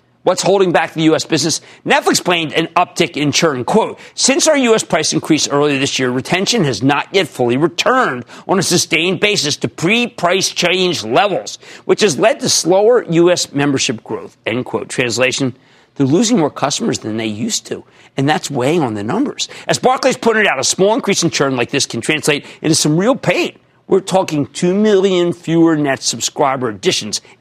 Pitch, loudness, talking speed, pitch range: 165 Hz, -14 LUFS, 190 wpm, 140-185 Hz